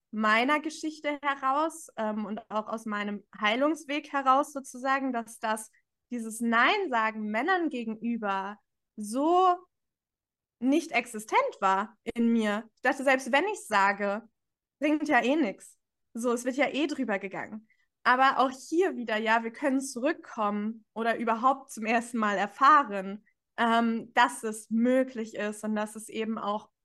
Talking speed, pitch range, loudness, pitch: 145 wpm, 215-275 Hz, -28 LUFS, 235 Hz